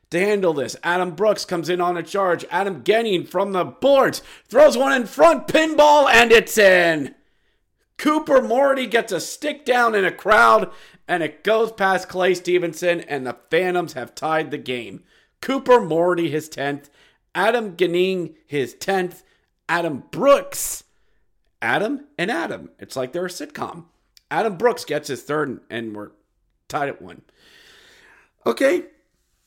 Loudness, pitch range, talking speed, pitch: -19 LUFS, 165-235 Hz, 150 wpm, 185 Hz